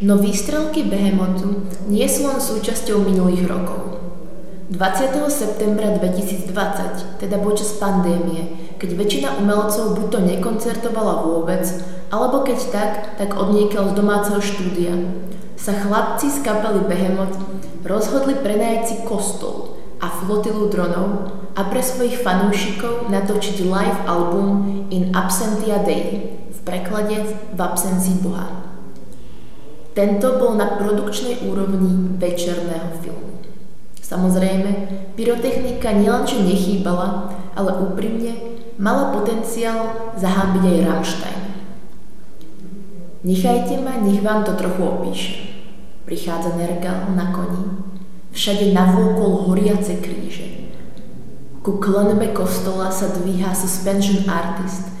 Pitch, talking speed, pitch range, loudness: 195 Hz, 105 wpm, 185-210 Hz, -20 LUFS